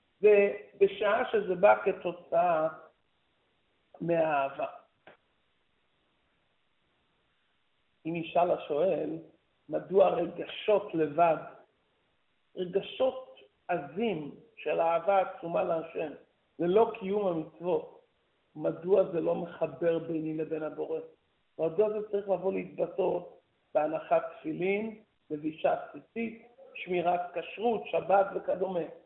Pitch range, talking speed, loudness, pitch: 165-220 Hz, 85 wpm, -30 LUFS, 190 Hz